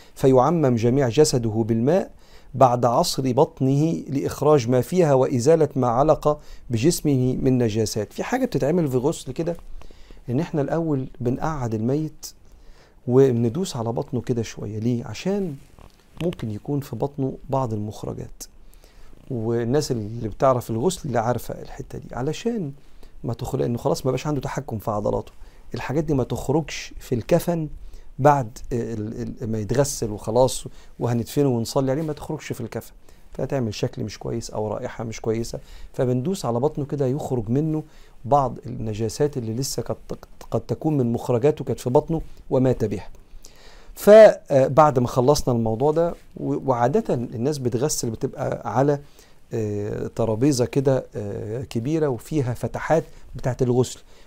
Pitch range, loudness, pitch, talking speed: 115-145 Hz, -22 LUFS, 130 Hz, 135 wpm